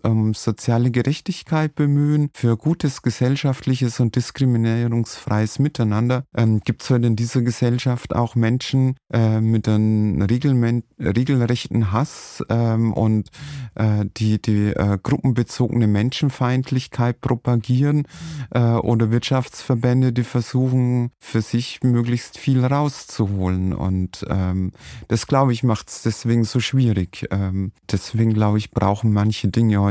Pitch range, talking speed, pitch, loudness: 110-130 Hz, 125 wpm, 120 Hz, -20 LUFS